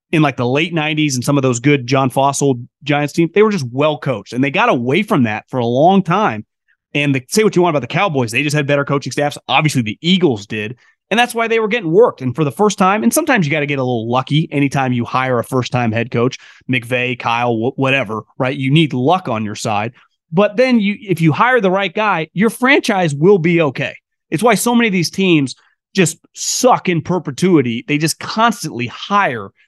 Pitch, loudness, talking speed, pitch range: 150 Hz, -15 LUFS, 235 wpm, 130-190 Hz